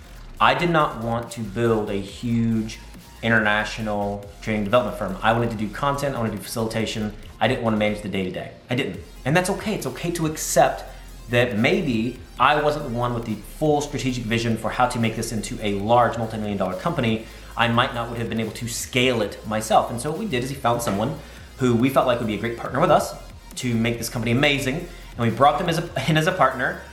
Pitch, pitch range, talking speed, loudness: 115 Hz, 110-130 Hz, 230 wpm, -23 LUFS